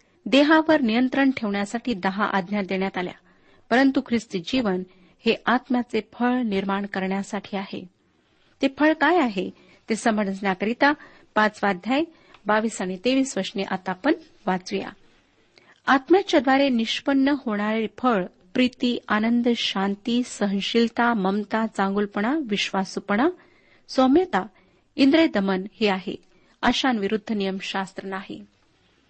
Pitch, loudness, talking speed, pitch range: 220 Hz, -23 LUFS, 100 wpm, 195-260 Hz